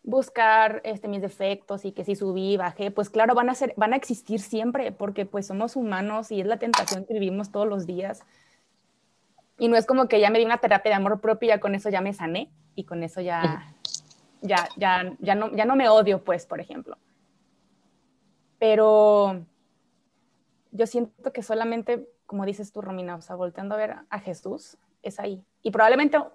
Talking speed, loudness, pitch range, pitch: 195 wpm, -24 LUFS, 195-225 Hz, 210 Hz